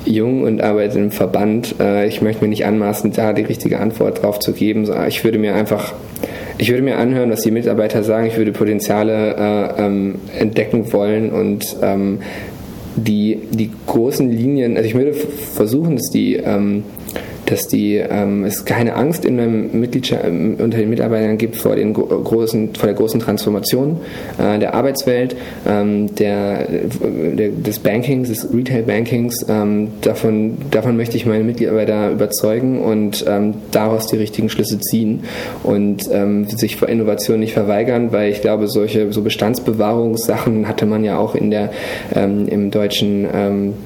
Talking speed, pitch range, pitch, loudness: 155 wpm, 105-115 Hz, 110 Hz, -16 LUFS